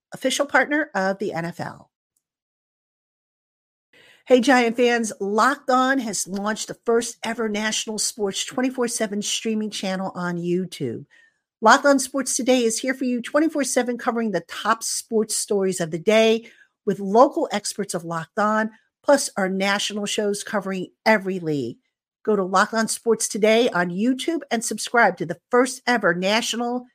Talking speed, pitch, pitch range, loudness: 150 wpm, 220 Hz, 200-250 Hz, -22 LUFS